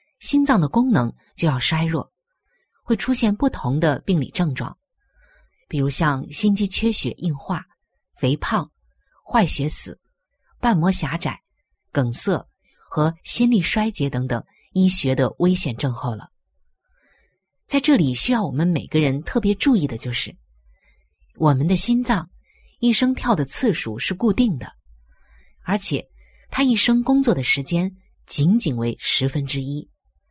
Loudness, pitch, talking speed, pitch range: -20 LUFS, 160 Hz, 205 characters per minute, 135-220 Hz